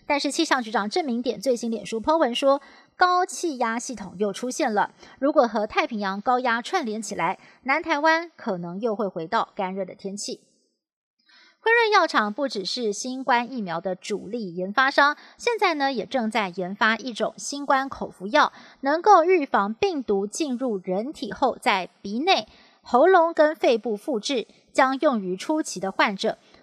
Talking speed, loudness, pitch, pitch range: 250 characters per minute, -24 LUFS, 245 Hz, 205-290 Hz